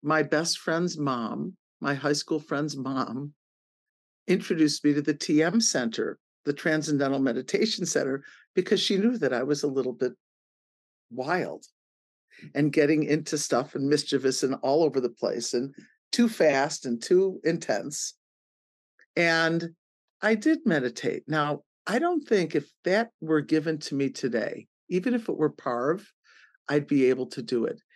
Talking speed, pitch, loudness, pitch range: 155 wpm, 155 Hz, -27 LUFS, 140-180 Hz